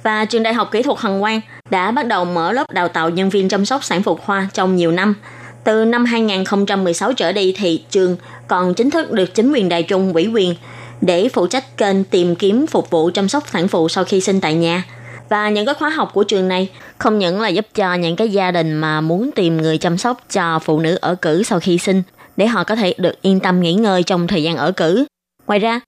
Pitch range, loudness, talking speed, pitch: 175-215 Hz, -16 LUFS, 245 wpm, 190 Hz